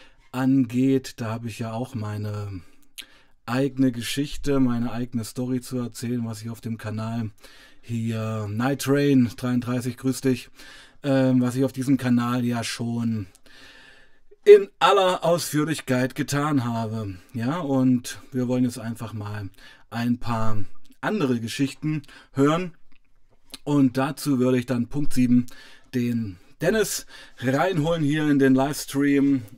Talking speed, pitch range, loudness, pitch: 130 wpm, 120-135 Hz, -24 LUFS, 130 Hz